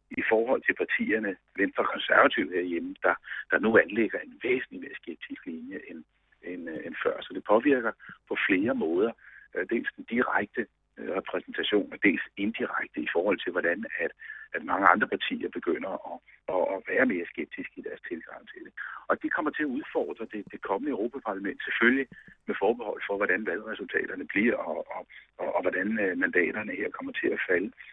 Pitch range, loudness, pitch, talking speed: 310-445 Hz, -28 LUFS, 390 Hz, 175 wpm